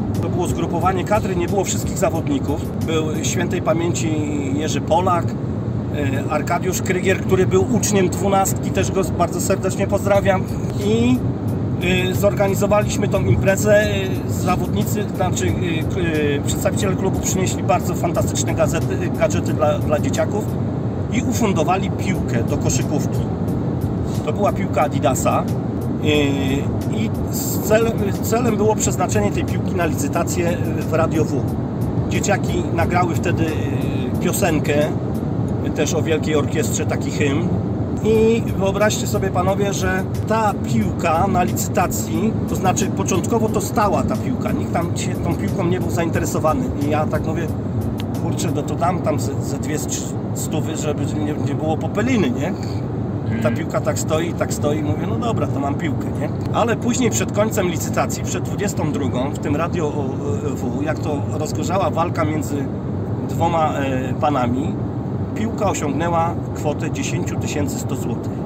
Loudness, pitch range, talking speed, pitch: -20 LUFS, 110-140 Hz, 125 wpm, 120 Hz